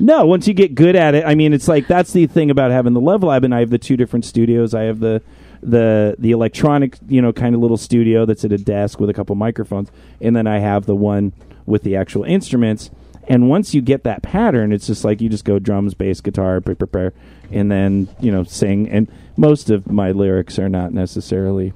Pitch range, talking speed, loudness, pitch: 100-125 Hz, 235 wpm, -15 LUFS, 110 Hz